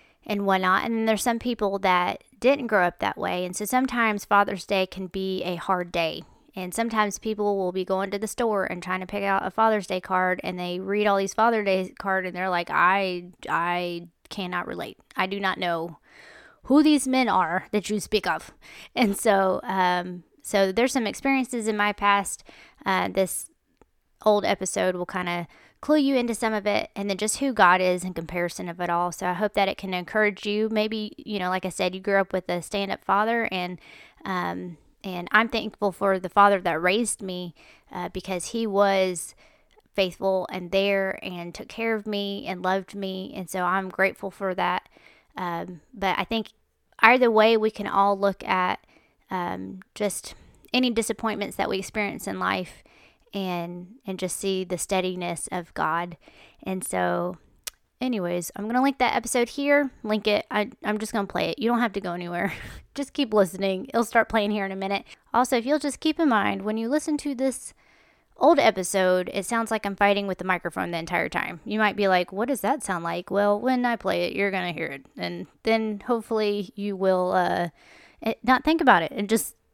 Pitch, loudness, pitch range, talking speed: 200 Hz, -25 LUFS, 185-220 Hz, 205 wpm